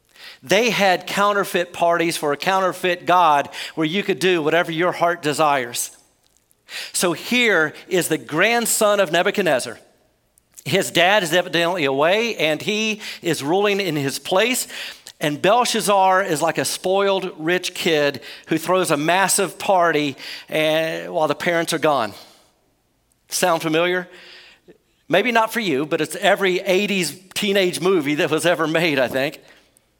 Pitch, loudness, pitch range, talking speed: 175 Hz, -19 LUFS, 160-195 Hz, 140 wpm